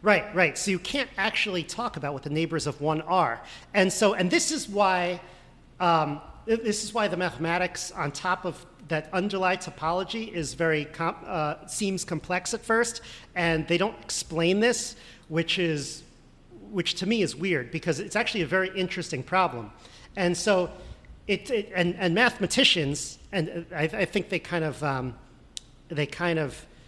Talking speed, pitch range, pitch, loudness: 175 wpm, 160-195 Hz, 180 Hz, -27 LUFS